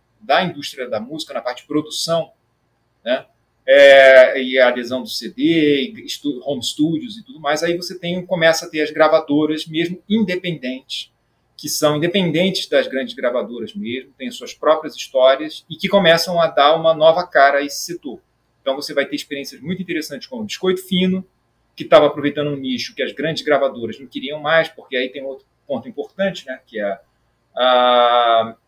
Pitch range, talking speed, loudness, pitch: 130-175 Hz, 180 wpm, -17 LUFS, 150 Hz